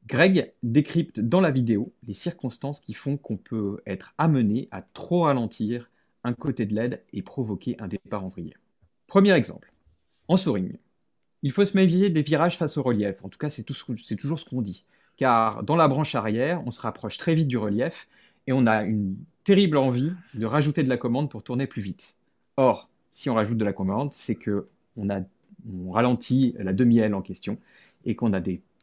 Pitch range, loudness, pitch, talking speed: 105-150 Hz, -25 LUFS, 120 Hz, 200 wpm